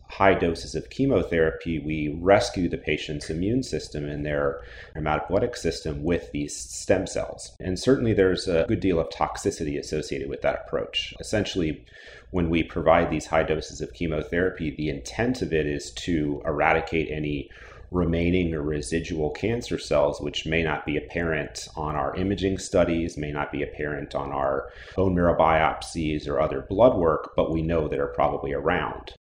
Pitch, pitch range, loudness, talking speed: 80 Hz, 75-90 Hz, -25 LUFS, 165 wpm